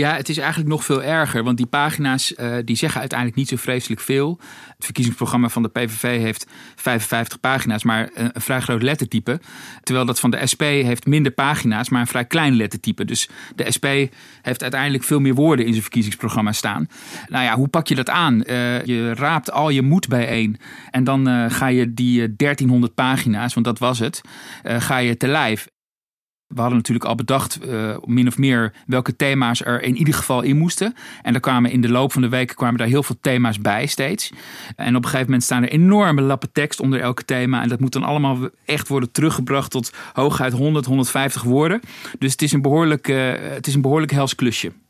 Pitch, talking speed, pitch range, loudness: 130 Hz, 210 wpm, 120-140 Hz, -19 LUFS